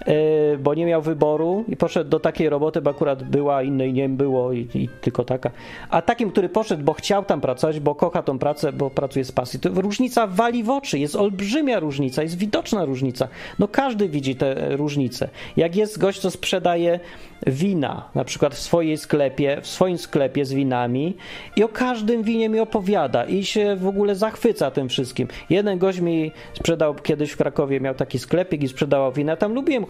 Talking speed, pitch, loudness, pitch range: 195 wpm, 160 Hz, -22 LUFS, 140-200 Hz